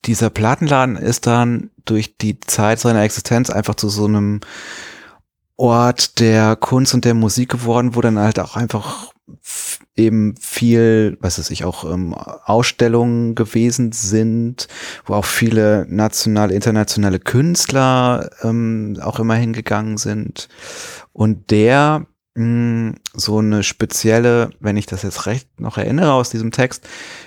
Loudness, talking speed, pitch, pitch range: -16 LUFS, 140 wpm, 115 Hz, 105-120 Hz